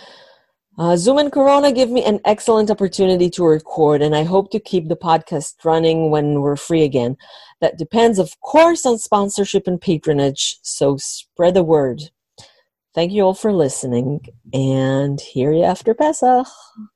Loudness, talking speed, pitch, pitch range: -17 LUFS, 160 wpm, 175 Hz, 150-215 Hz